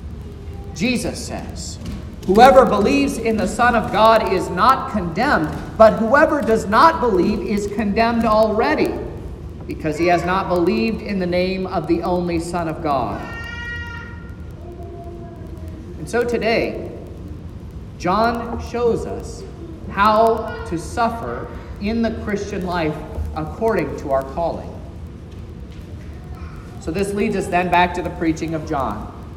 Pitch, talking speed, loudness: 175 Hz, 125 wpm, -18 LUFS